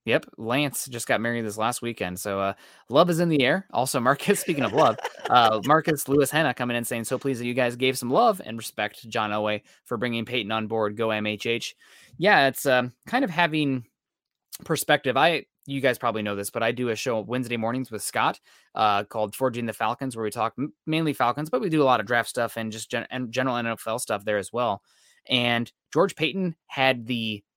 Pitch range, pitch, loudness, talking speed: 110-140 Hz, 120 Hz, -25 LUFS, 225 wpm